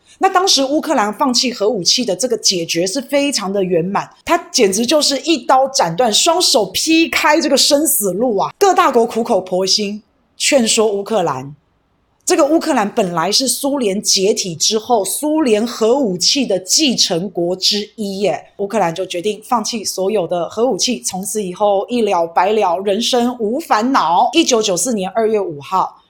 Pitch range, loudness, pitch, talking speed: 190-275 Hz, -15 LUFS, 220 Hz, 265 characters per minute